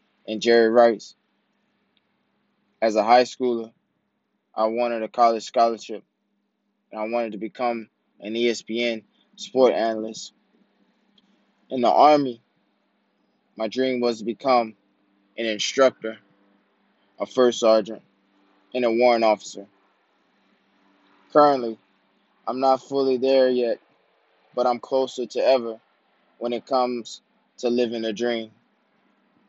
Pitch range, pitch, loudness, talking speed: 110-125 Hz, 115 Hz, -22 LUFS, 115 wpm